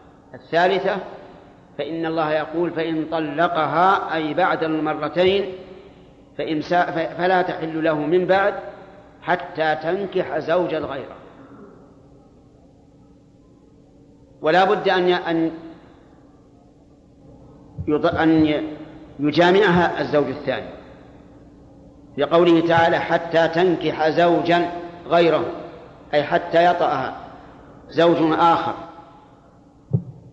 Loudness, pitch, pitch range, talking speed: -20 LUFS, 165 Hz, 150-175 Hz, 70 wpm